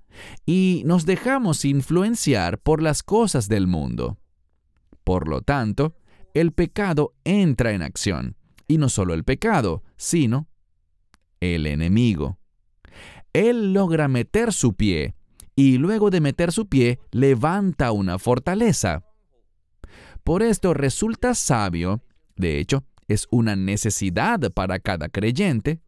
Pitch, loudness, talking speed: 125 Hz, -21 LUFS, 120 wpm